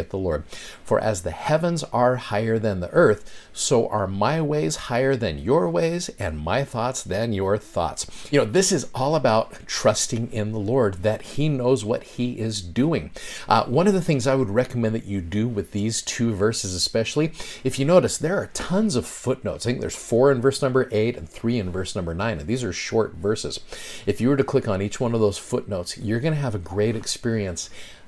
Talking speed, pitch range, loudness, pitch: 220 wpm, 105-135 Hz, -23 LUFS, 115 Hz